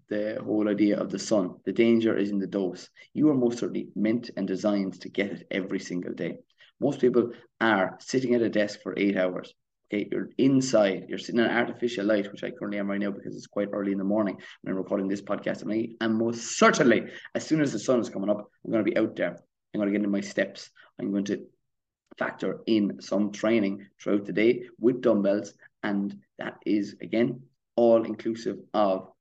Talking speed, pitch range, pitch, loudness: 215 wpm, 100-115 Hz, 105 Hz, -27 LUFS